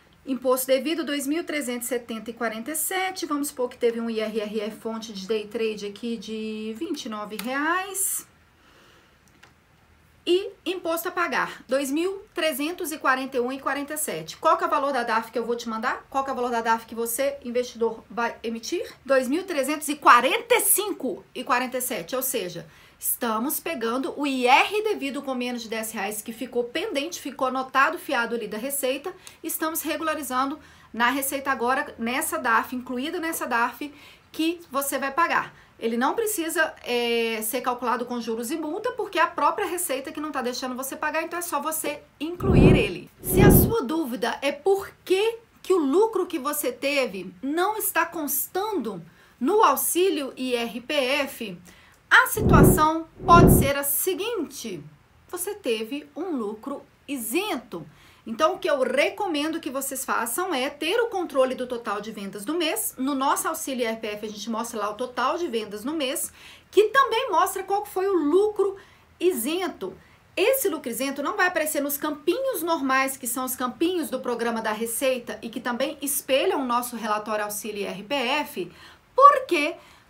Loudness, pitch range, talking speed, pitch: -24 LUFS, 240-330 Hz, 155 wpm, 275 Hz